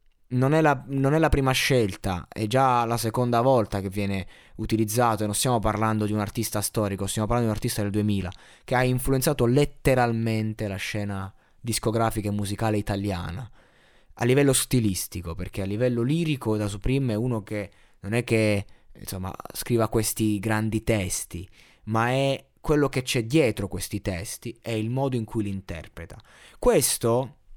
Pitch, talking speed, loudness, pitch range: 110 Hz, 170 wpm, -25 LUFS, 105-125 Hz